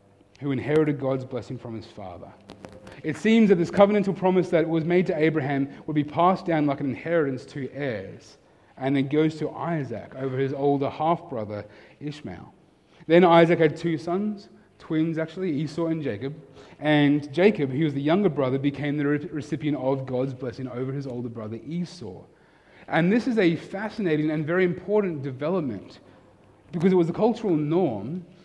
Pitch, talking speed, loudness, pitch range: 150 Hz, 175 wpm, -24 LUFS, 135-170 Hz